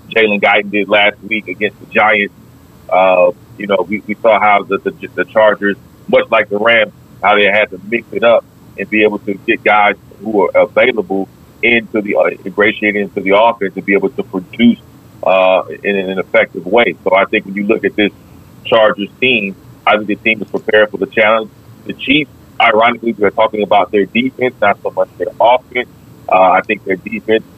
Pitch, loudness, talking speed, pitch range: 105 Hz, -12 LUFS, 205 wpm, 95-115 Hz